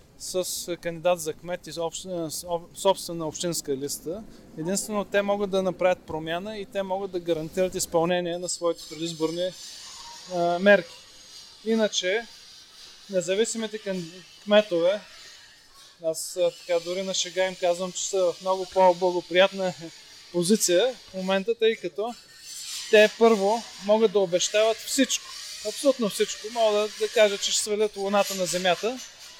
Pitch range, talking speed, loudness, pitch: 170-210 Hz, 125 wpm, -25 LUFS, 185 Hz